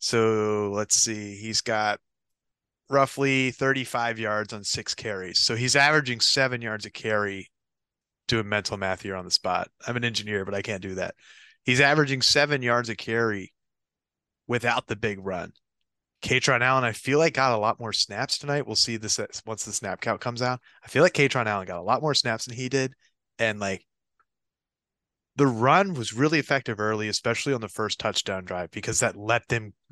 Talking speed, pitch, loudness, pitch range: 190 wpm, 115 Hz, -25 LUFS, 105-130 Hz